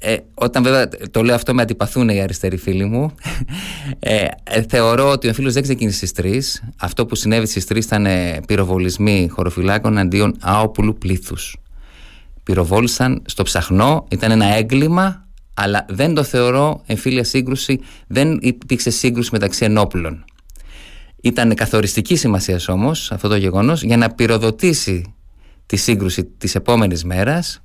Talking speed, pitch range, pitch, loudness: 140 wpm, 95-125 Hz, 110 Hz, -17 LUFS